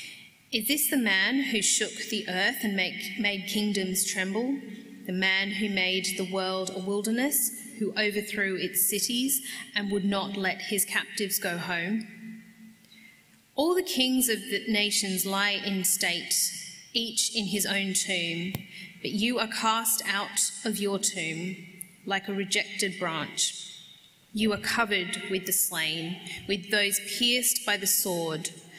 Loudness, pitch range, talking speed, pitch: -27 LUFS, 185-220 Hz, 150 wpm, 200 Hz